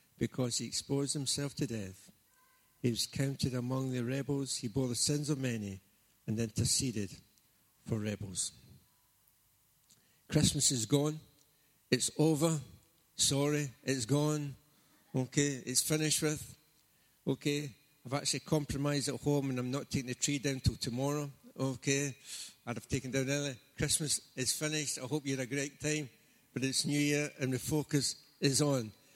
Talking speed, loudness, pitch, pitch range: 150 wpm, -34 LUFS, 140 Hz, 125-145 Hz